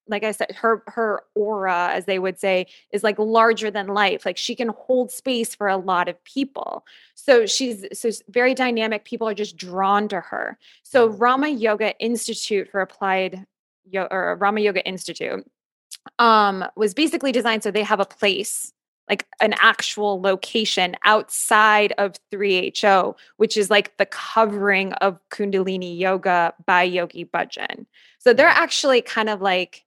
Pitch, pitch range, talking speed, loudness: 205 Hz, 190-225 Hz, 160 wpm, -20 LUFS